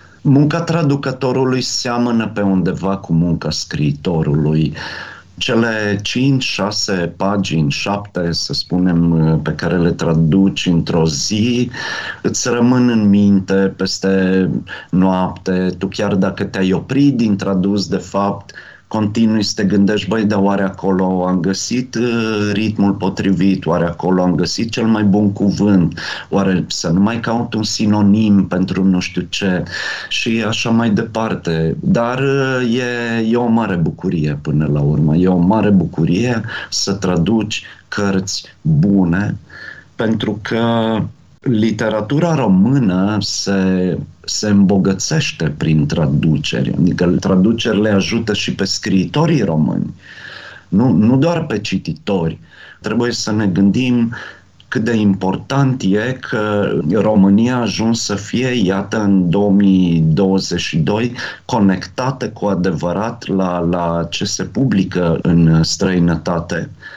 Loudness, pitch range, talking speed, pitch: -16 LUFS, 90-115 Hz, 120 wpm, 100 Hz